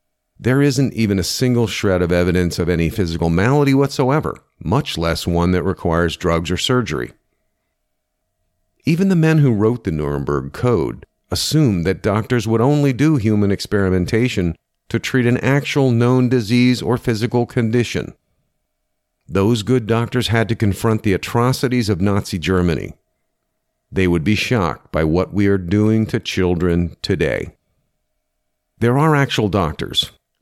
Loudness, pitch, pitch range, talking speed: -17 LUFS, 105 Hz, 90-125 Hz, 145 wpm